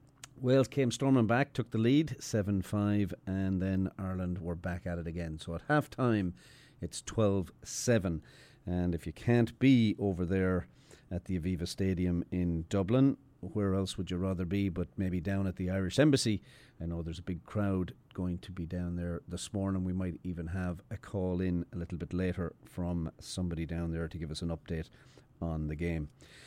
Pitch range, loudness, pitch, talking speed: 85-110 Hz, -33 LUFS, 95 Hz, 195 wpm